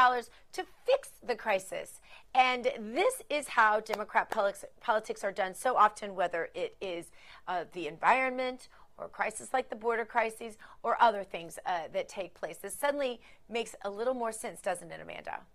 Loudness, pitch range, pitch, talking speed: -32 LUFS, 205-255 Hz, 230 Hz, 165 wpm